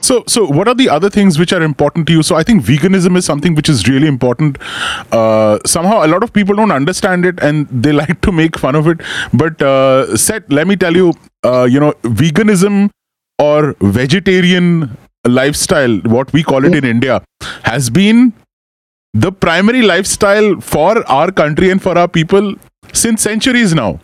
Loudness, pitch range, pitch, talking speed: -11 LUFS, 140-195 Hz, 165 Hz, 185 wpm